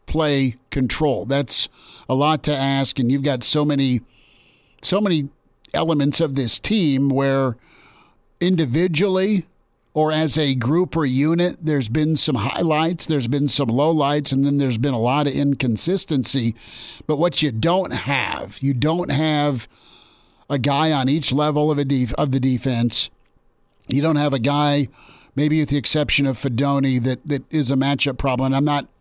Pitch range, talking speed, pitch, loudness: 130-155 Hz, 170 wpm, 140 Hz, -20 LUFS